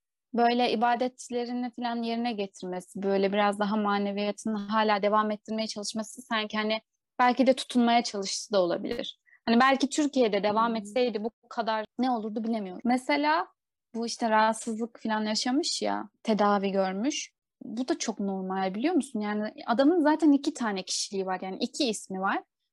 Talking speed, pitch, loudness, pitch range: 150 wpm, 225 Hz, -28 LUFS, 210-250 Hz